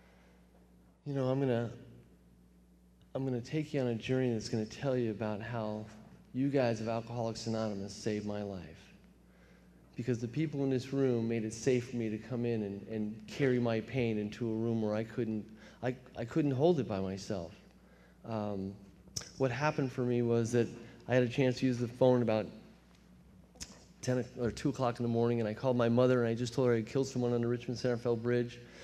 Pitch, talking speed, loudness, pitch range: 115 Hz, 210 wpm, -34 LUFS, 105-125 Hz